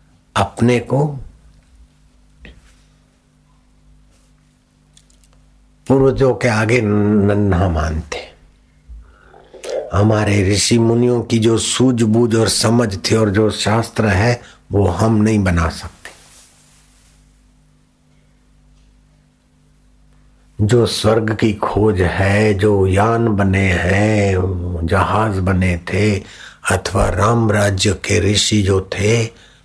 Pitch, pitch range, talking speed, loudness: 105 Hz, 90-110 Hz, 85 wpm, -15 LUFS